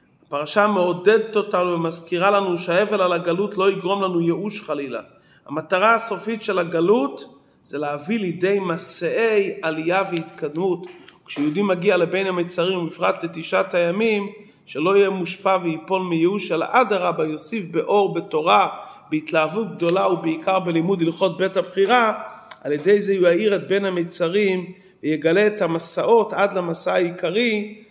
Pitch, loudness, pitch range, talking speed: 185 Hz, -21 LUFS, 170-200 Hz, 130 wpm